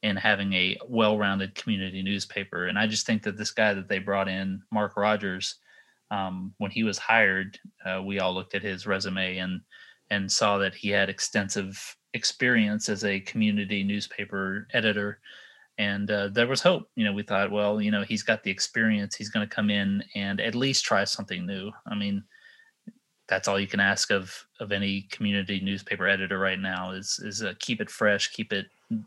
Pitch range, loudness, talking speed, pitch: 95-105 Hz, -27 LUFS, 195 wpm, 100 Hz